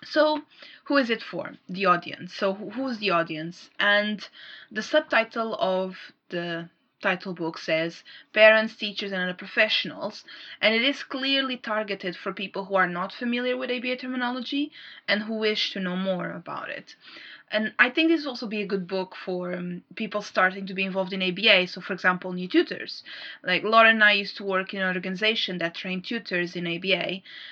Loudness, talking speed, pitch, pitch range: -25 LUFS, 185 wpm, 195 Hz, 185-225 Hz